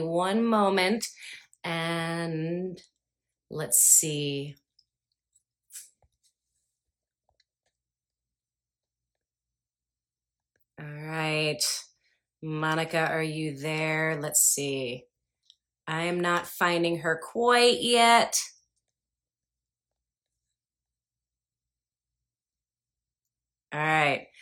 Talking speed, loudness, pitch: 55 wpm, -25 LUFS, 150 Hz